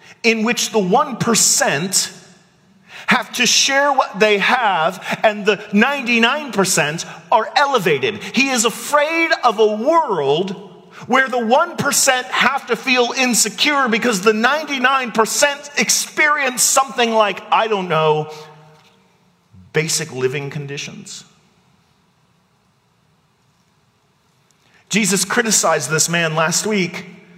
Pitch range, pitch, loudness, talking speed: 170-250 Hz, 210 Hz, -16 LUFS, 100 wpm